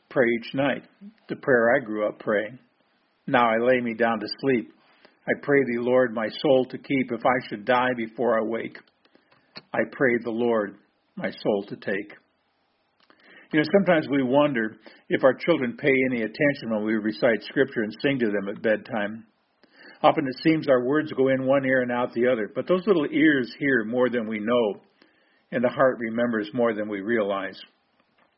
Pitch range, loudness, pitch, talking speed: 110-135 Hz, -24 LUFS, 120 Hz, 190 wpm